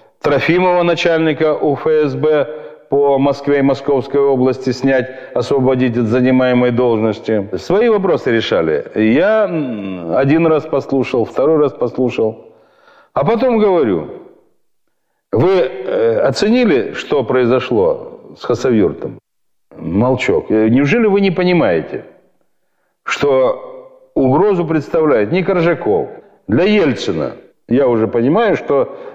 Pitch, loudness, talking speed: 155 Hz, -14 LUFS, 100 wpm